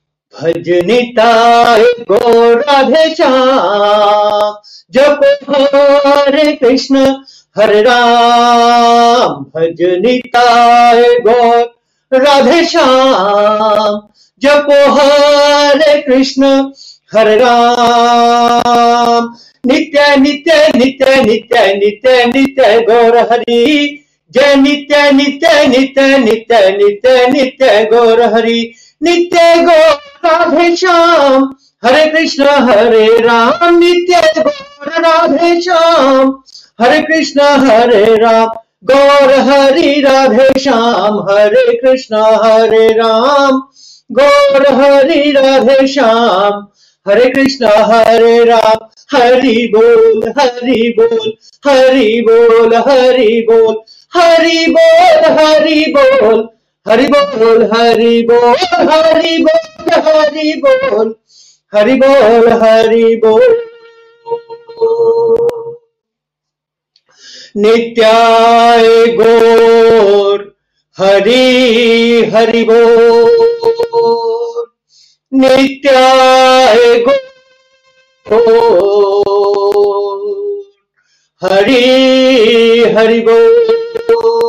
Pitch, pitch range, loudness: 260 Hz, 230-290 Hz, -7 LUFS